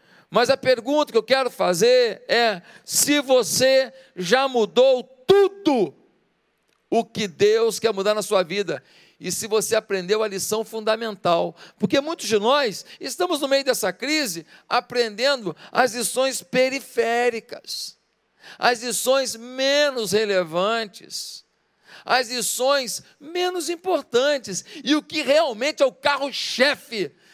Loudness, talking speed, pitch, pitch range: -21 LUFS, 125 wpm, 245 Hz, 220-280 Hz